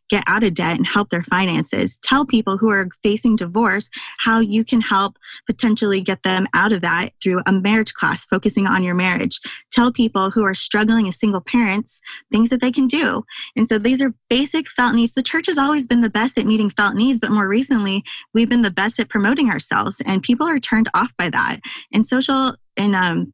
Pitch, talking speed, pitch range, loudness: 220 Hz, 215 wpm, 195-250 Hz, -17 LUFS